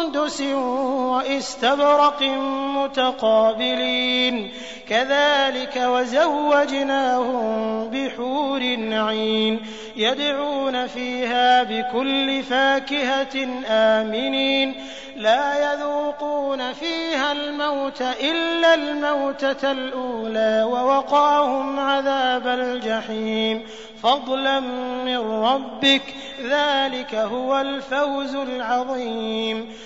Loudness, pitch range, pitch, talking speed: -21 LUFS, 230-275 Hz, 260 Hz, 55 wpm